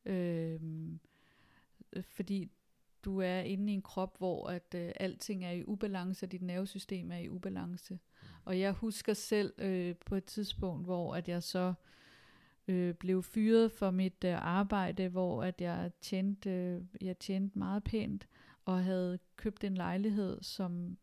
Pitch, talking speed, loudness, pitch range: 185 Hz, 155 wpm, -37 LUFS, 175-195 Hz